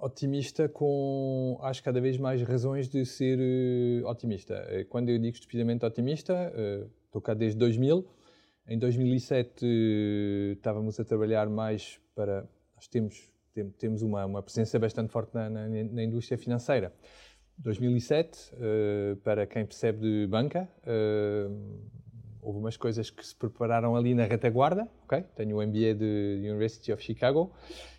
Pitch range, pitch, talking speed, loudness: 110-125 Hz, 115 Hz, 150 wpm, -30 LUFS